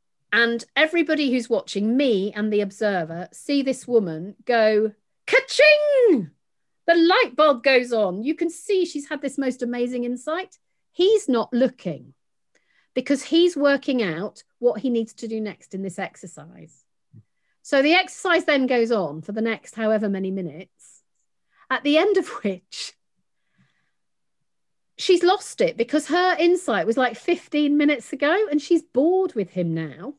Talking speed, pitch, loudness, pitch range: 155 wpm, 255 Hz, -21 LUFS, 215-315 Hz